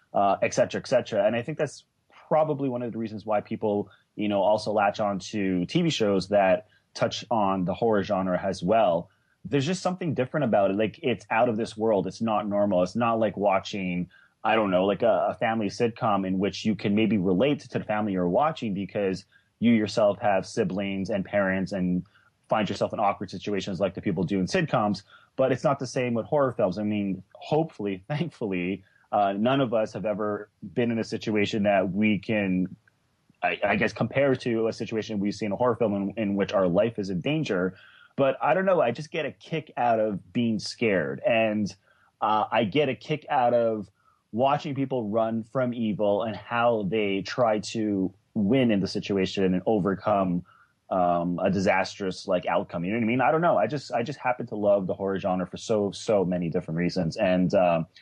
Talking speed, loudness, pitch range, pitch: 210 wpm, -26 LUFS, 95-120 Hz, 105 Hz